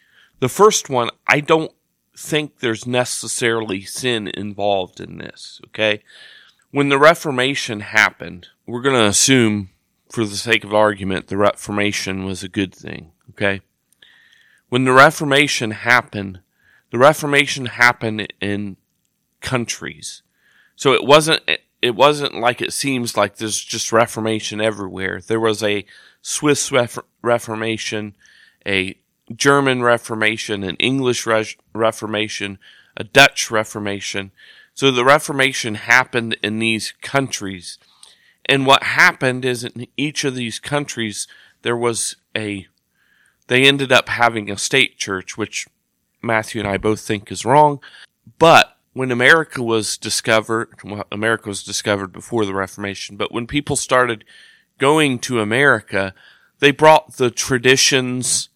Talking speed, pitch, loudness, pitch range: 130 wpm, 115 Hz, -17 LUFS, 105-130 Hz